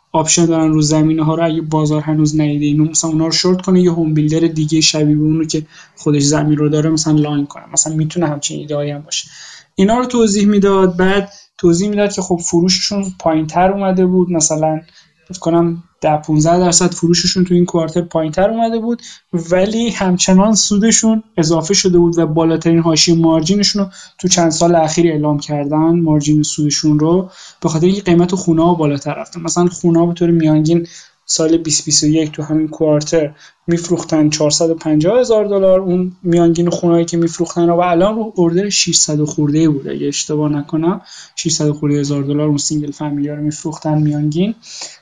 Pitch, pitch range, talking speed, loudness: 165 Hz, 155-180 Hz, 175 wpm, -14 LUFS